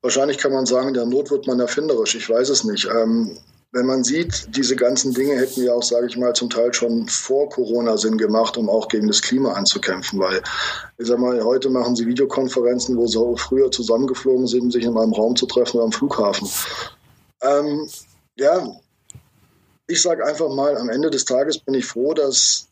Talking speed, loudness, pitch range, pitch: 200 wpm, -19 LUFS, 120-135 Hz, 125 Hz